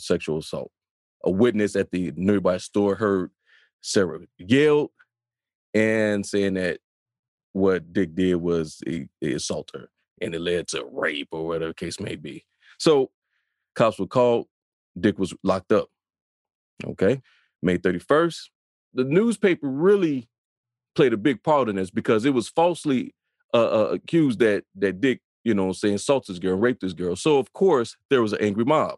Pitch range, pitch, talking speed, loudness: 95-125 Hz, 105 Hz, 165 wpm, -23 LUFS